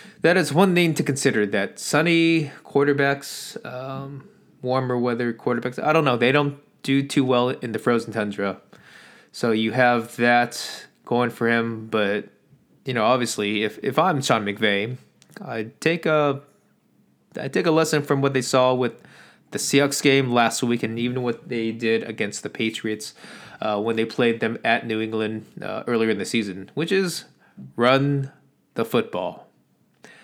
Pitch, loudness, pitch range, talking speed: 125 Hz, -22 LUFS, 115-140 Hz, 165 wpm